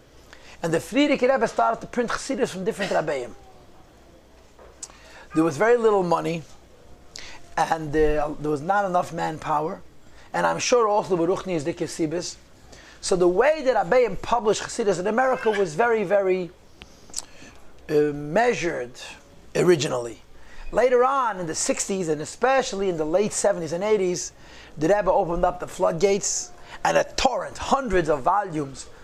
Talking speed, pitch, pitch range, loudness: 145 wpm, 185 Hz, 165-225 Hz, -23 LUFS